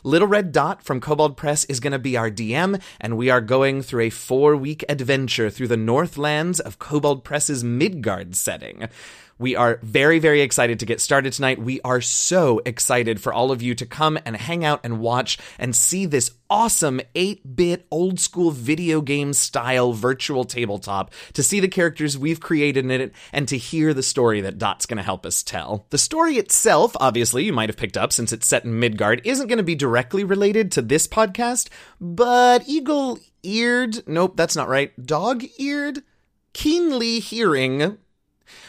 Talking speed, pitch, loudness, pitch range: 185 wpm, 145 Hz, -20 LUFS, 125-180 Hz